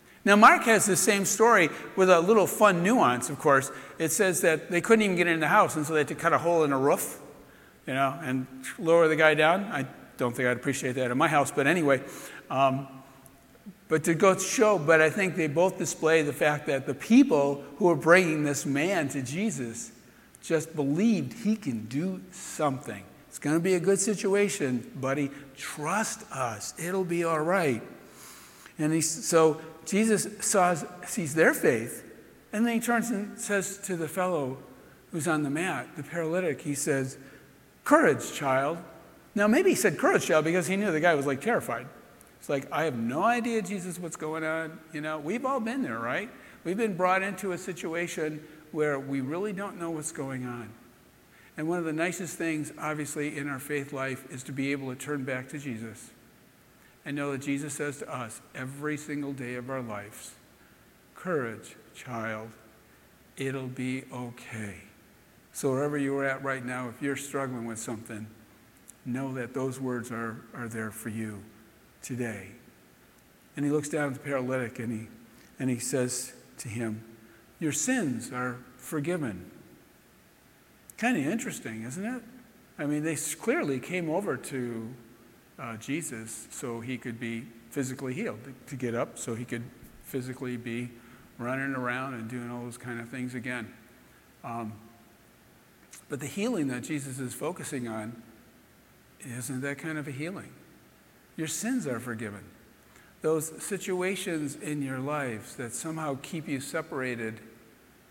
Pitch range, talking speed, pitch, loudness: 125-170 Hz, 175 wpm, 145 Hz, -28 LUFS